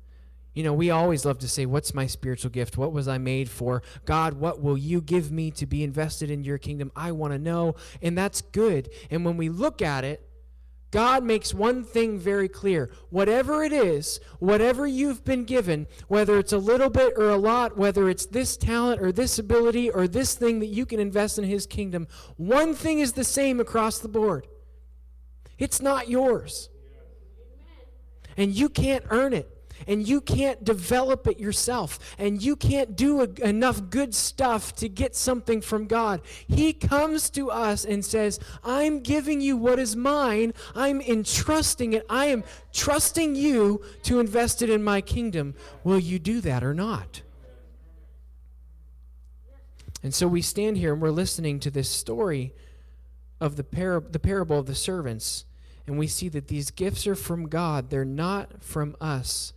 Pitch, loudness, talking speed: 190 Hz, -25 LUFS, 180 wpm